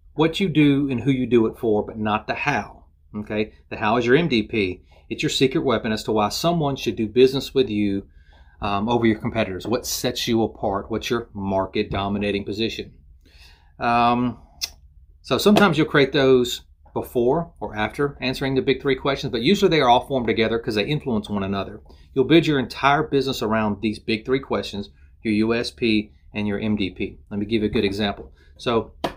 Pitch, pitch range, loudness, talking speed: 110 Hz, 100-130 Hz, -22 LUFS, 195 wpm